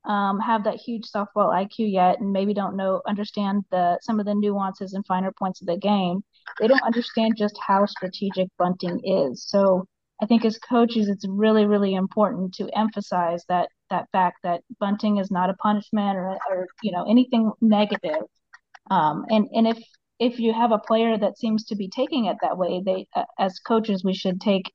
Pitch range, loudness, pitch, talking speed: 190-220 Hz, -23 LUFS, 205 Hz, 195 wpm